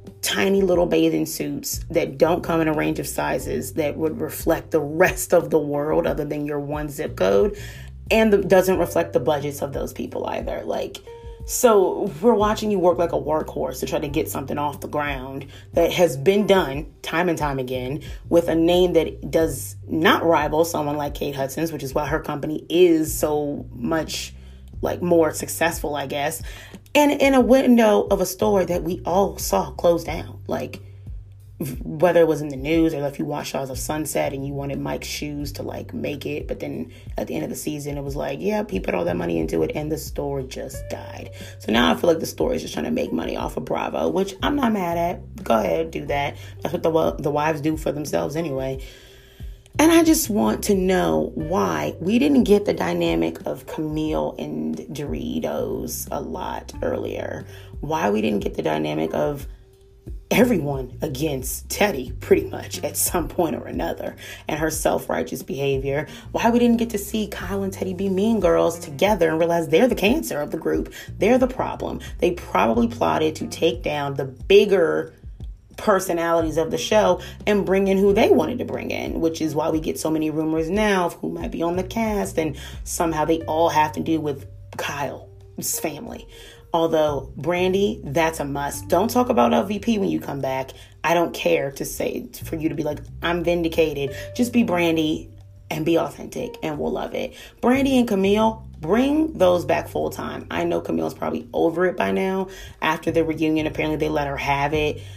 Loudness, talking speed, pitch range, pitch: -22 LUFS, 200 wpm, 125-180 Hz, 155 Hz